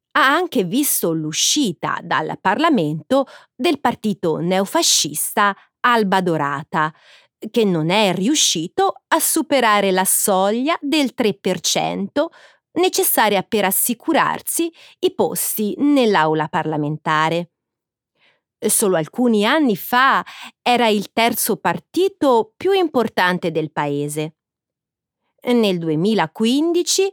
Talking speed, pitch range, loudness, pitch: 95 wpm, 170-290 Hz, -18 LUFS, 215 Hz